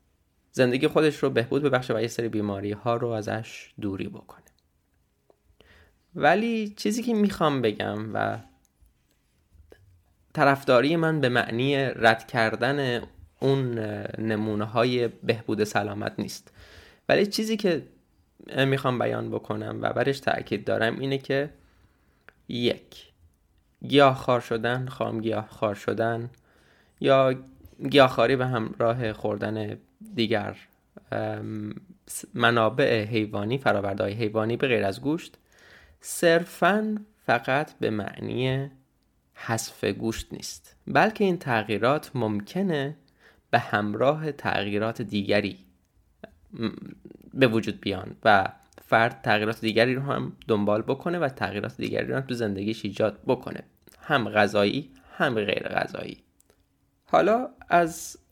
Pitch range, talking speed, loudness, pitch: 105-135 Hz, 110 wpm, -26 LUFS, 115 Hz